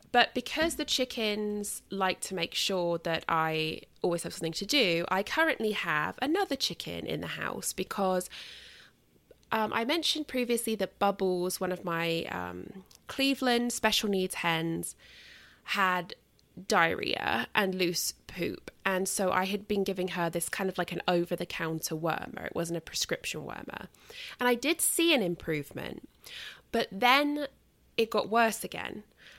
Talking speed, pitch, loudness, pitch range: 155 wpm, 195 Hz, -30 LUFS, 170-240 Hz